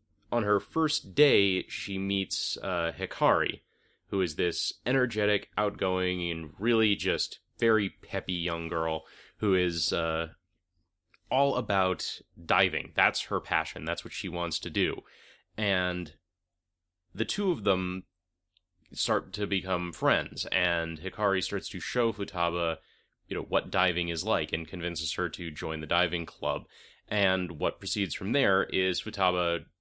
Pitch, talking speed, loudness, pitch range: 90 Hz, 145 wpm, -29 LUFS, 85-100 Hz